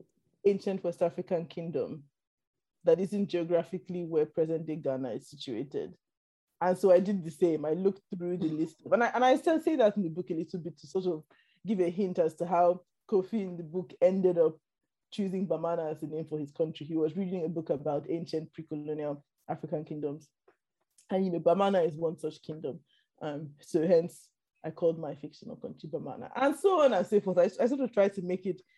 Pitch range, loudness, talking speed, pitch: 160-190 Hz, -31 LUFS, 210 wpm, 175 Hz